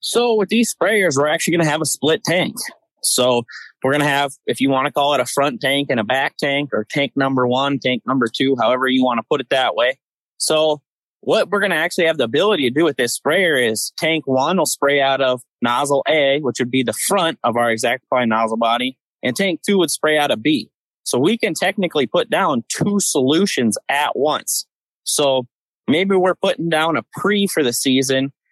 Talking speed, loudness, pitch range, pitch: 225 wpm, -18 LUFS, 130-165 Hz, 140 Hz